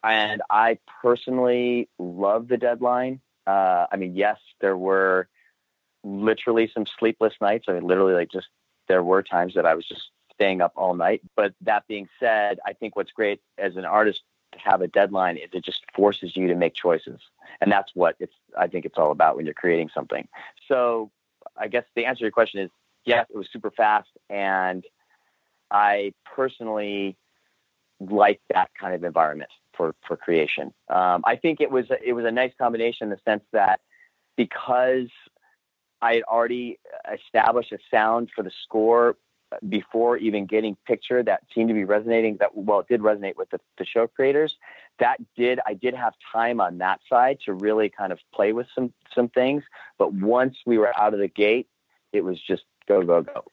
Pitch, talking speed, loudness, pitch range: 110 Hz, 190 wpm, -23 LUFS, 100-120 Hz